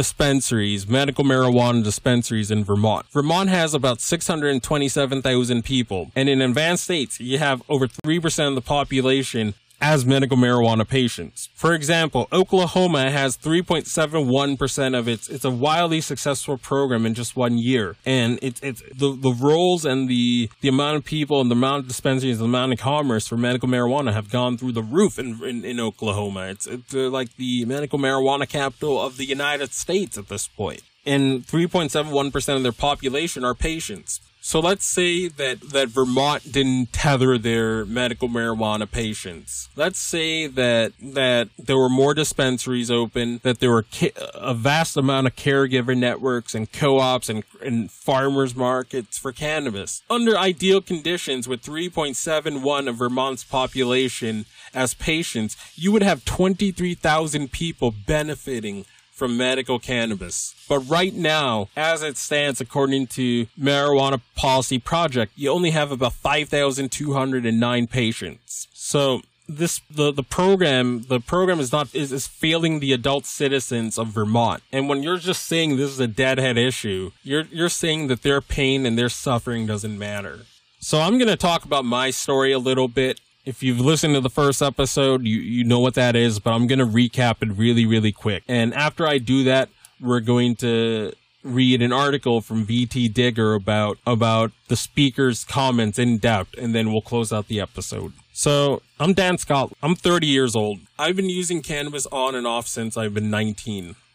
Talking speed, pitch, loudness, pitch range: 170 wpm, 130 Hz, -21 LUFS, 120-145 Hz